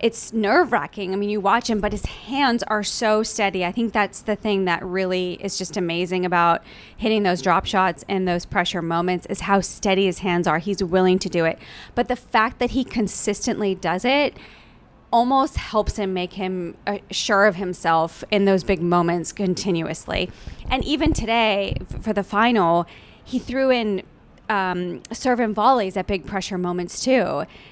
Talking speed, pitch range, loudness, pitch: 180 wpm, 180-220 Hz, -21 LUFS, 200 Hz